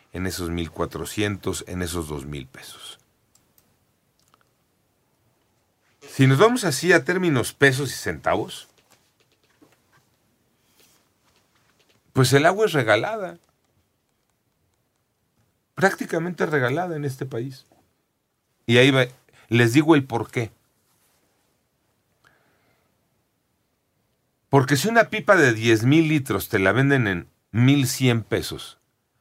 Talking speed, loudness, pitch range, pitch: 90 wpm, -21 LUFS, 105-145 Hz, 125 Hz